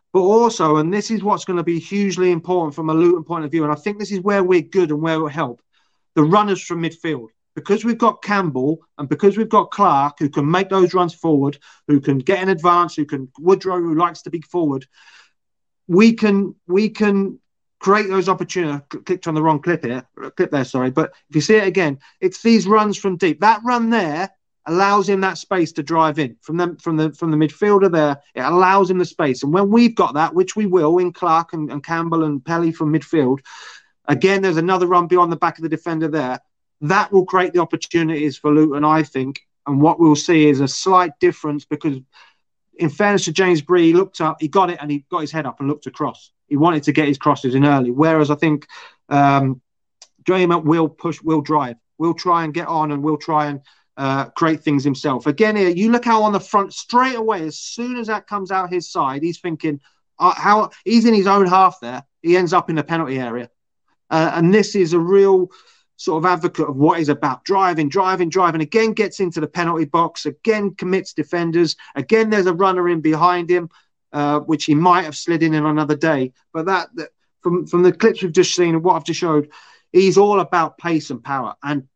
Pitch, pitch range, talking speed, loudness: 170 Hz, 150-190 Hz, 225 wpm, -17 LUFS